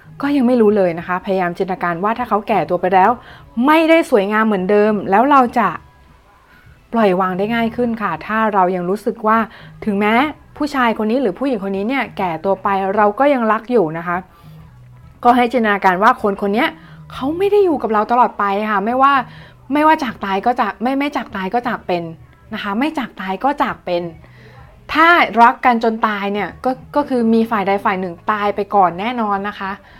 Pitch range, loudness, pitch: 190-245 Hz, -16 LUFS, 215 Hz